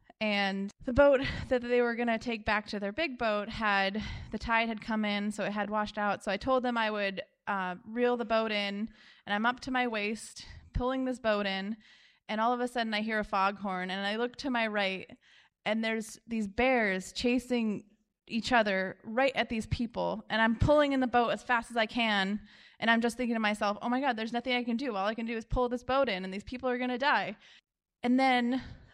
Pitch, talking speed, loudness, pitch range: 225 Hz, 235 wpm, -31 LUFS, 210-245 Hz